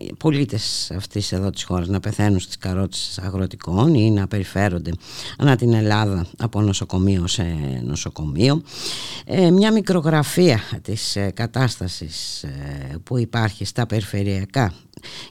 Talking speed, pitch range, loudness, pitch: 120 wpm, 95-120 Hz, -21 LUFS, 100 Hz